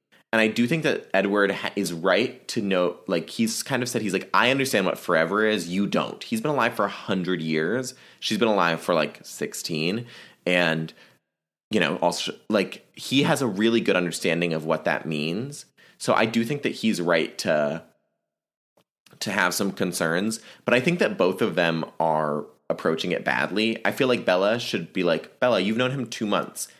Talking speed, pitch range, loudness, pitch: 195 wpm, 85-115 Hz, -24 LUFS, 100 Hz